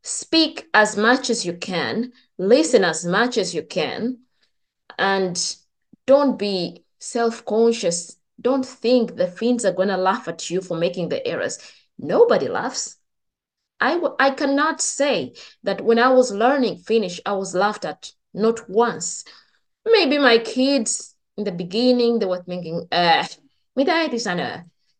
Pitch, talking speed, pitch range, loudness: 230 Hz, 145 wpm, 185-255 Hz, -20 LUFS